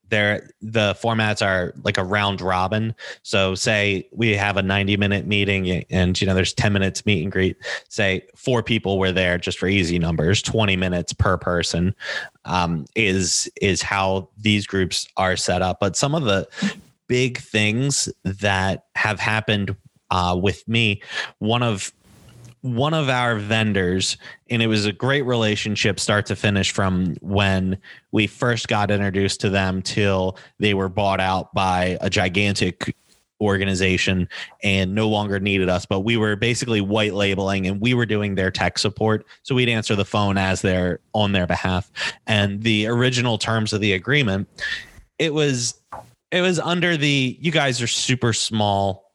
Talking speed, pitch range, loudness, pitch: 165 wpm, 95-115 Hz, -21 LUFS, 100 Hz